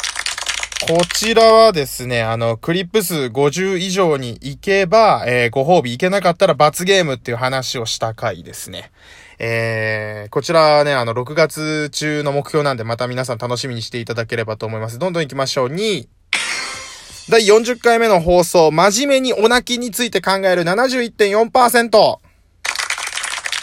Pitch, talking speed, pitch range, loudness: 155 Hz, 295 characters per minute, 125-200 Hz, -16 LUFS